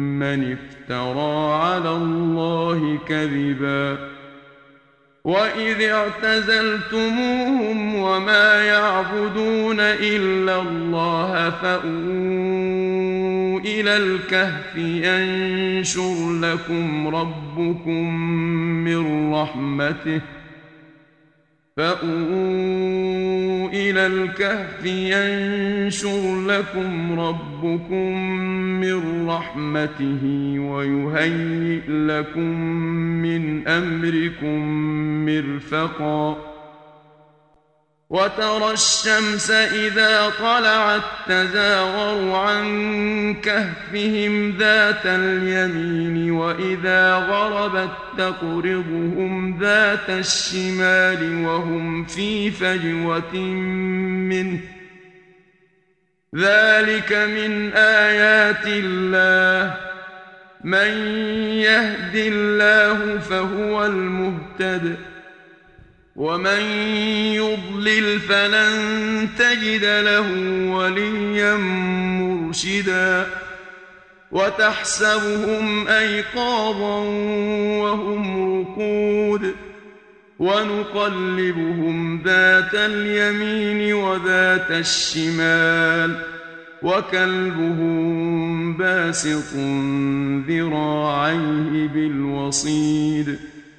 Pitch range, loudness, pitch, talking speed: 165-210 Hz, -19 LUFS, 185 Hz, 50 wpm